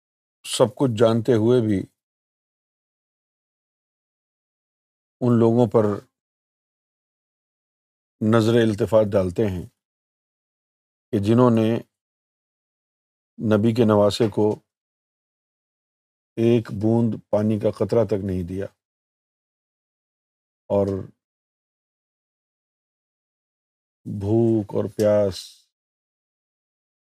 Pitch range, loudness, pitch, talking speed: 105-115 Hz, -21 LUFS, 110 Hz, 70 wpm